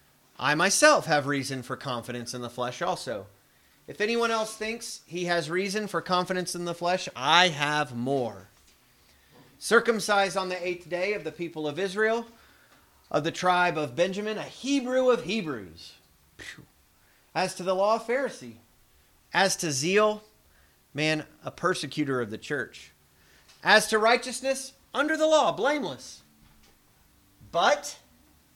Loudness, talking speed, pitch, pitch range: -26 LUFS, 140 wpm, 175 Hz, 125-215 Hz